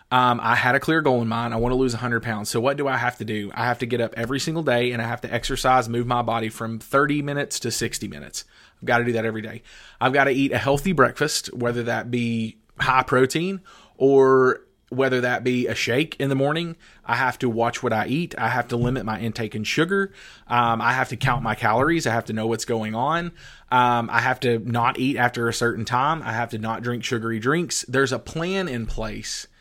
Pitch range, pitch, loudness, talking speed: 115-135 Hz, 120 Hz, -22 LUFS, 245 wpm